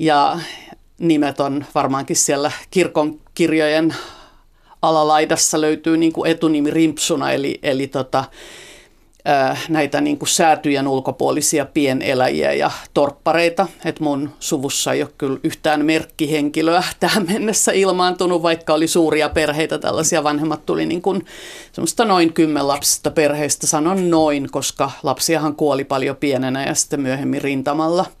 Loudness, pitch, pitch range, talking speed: -18 LUFS, 155 Hz, 145-165 Hz, 125 wpm